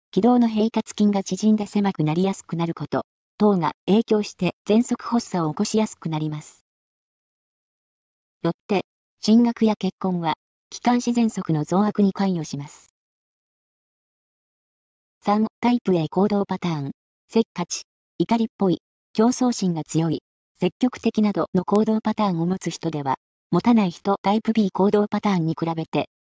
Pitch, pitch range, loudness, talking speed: 195 Hz, 170-215 Hz, -22 LUFS, 290 characters per minute